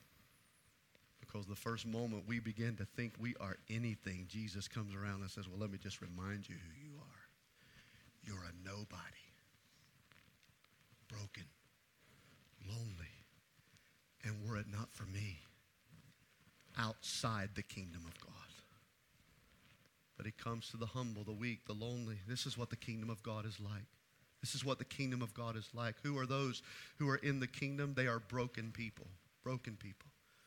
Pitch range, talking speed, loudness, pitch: 100-120 Hz, 160 wpm, -45 LUFS, 110 Hz